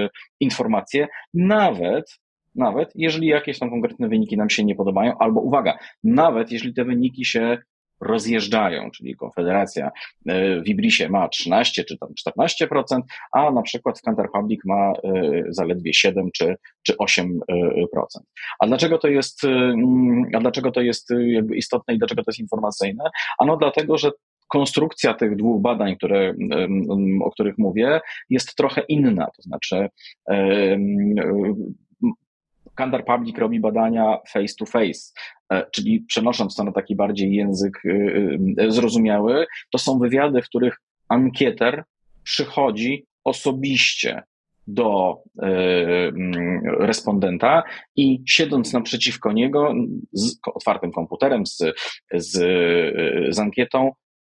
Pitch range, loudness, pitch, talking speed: 105-155 Hz, -20 LUFS, 125 Hz, 120 wpm